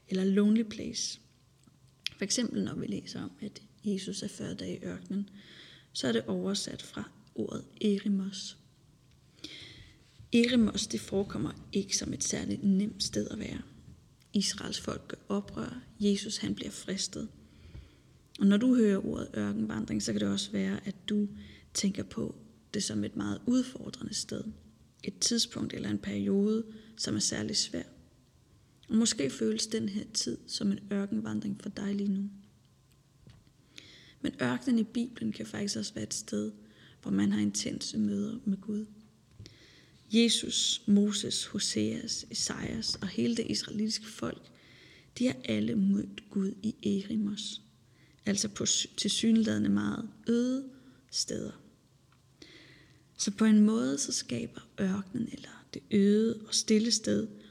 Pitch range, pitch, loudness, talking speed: 130-220 Hz, 200 Hz, -31 LUFS, 145 wpm